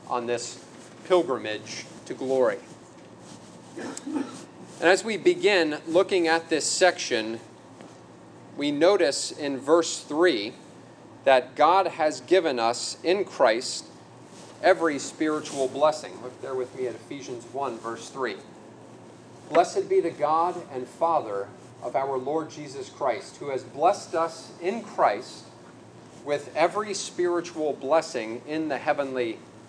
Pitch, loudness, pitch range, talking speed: 155 Hz, -25 LUFS, 125-175 Hz, 125 wpm